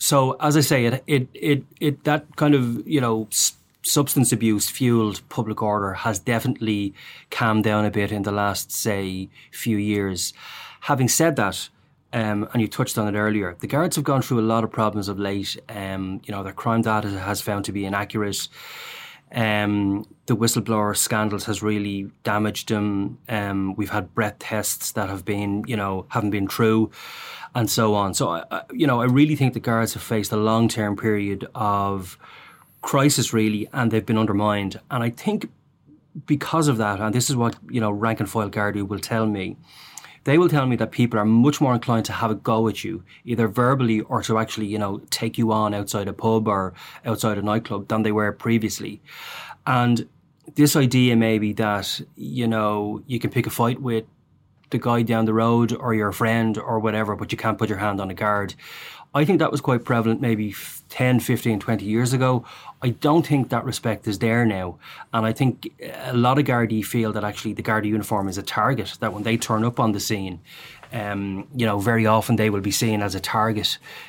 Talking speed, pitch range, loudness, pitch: 205 wpm, 105-120 Hz, -22 LUFS, 110 Hz